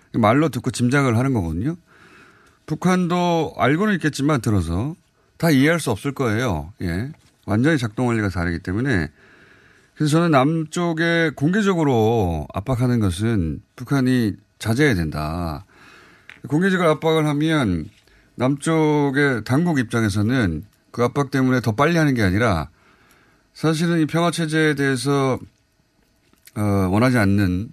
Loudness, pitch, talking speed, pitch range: -20 LUFS, 130 Hz, 285 characters per minute, 105-155 Hz